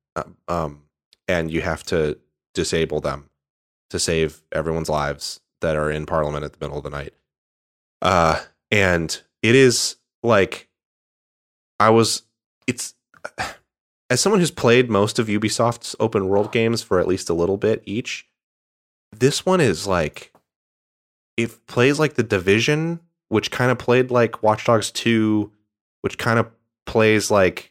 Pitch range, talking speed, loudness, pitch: 75-115 Hz, 145 wpm, -20 LUFS, 105 Hz